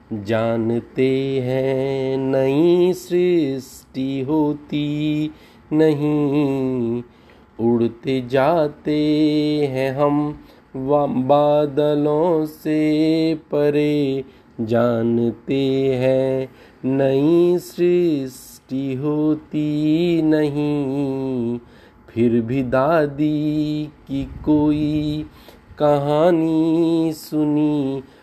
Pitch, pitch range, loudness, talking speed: 145 Hz, 130-150 Hz, -19 LUFS, 55 wpm